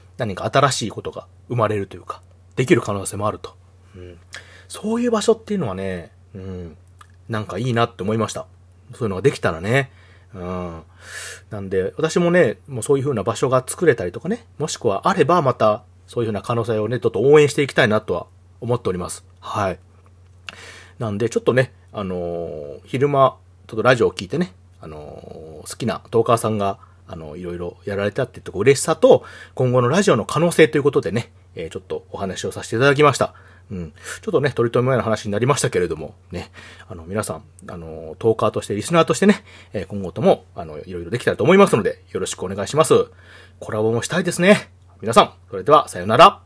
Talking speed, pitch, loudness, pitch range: 420 characters per minute, 105 Hz, -19 LUFS, 90-130 Hz